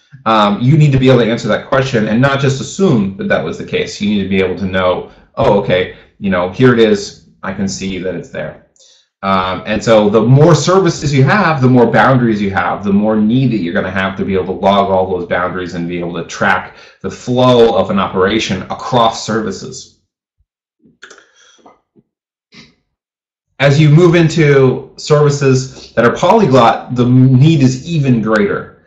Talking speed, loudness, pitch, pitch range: 195 wpm, -12 LUFS, 120 Hz, 100-140 Hz